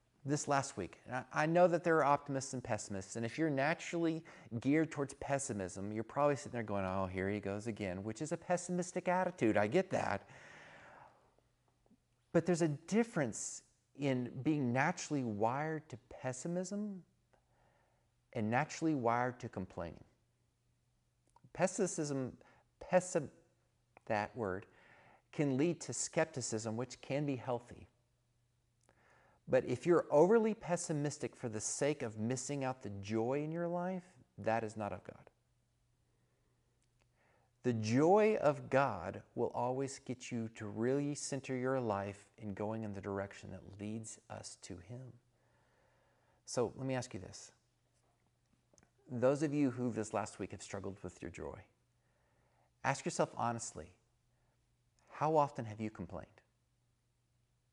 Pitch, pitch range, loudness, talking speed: 125 Hz, 110-145 Hz, -37 LUFS, 135 wpm